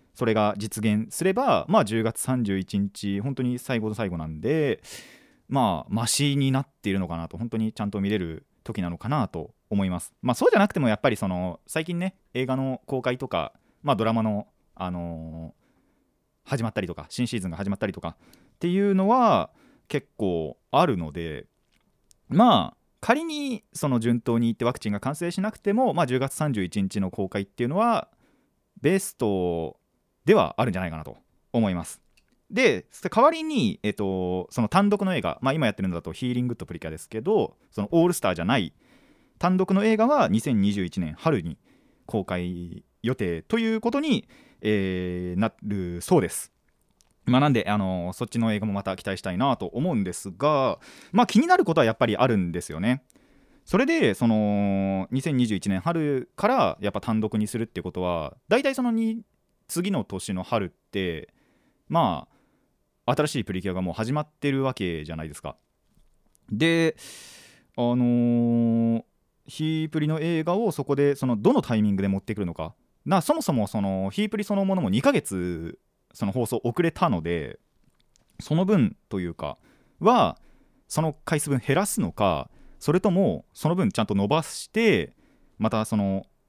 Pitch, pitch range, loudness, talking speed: 115 Hz, 95-160 Hz, -25 LUFS, 325 characters per minute